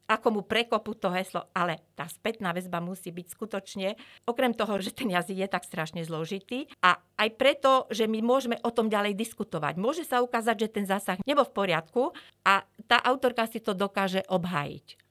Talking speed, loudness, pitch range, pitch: 185 wpm, -28 LUFS, 180-235 Hz, 205 Hz